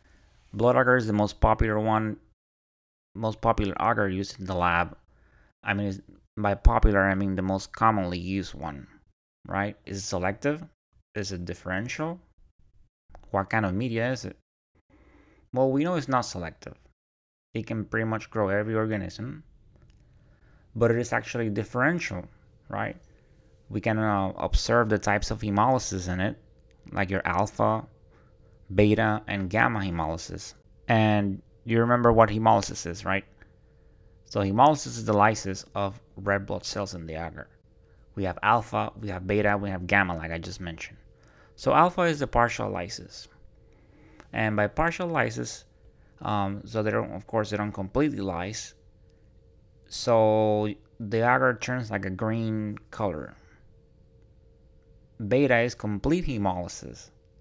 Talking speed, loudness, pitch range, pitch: 145 wpm, -27 LUFS, 95-115 Hz, 105 Hz